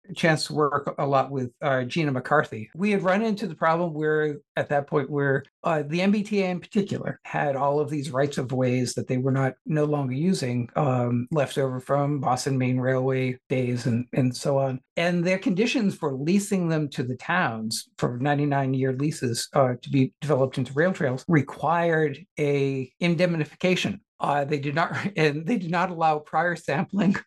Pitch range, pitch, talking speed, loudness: 135-170 Hz, 145 Hz, 185 wpm, -25 LUFS